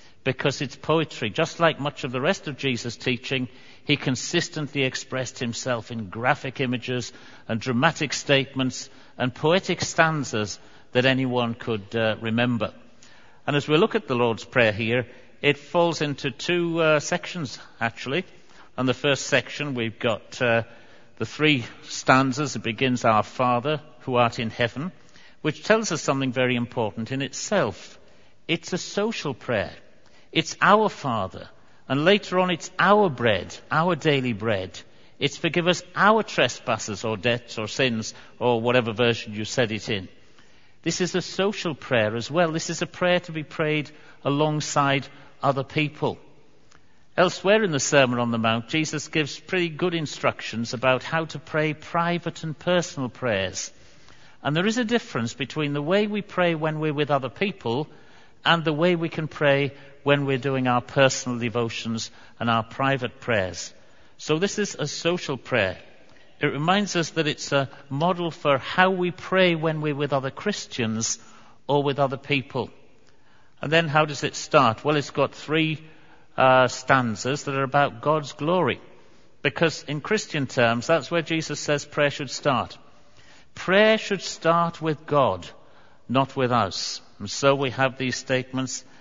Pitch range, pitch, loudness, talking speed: 125-160 Hz, 140 Hz, -24 LUFS, 160 wpm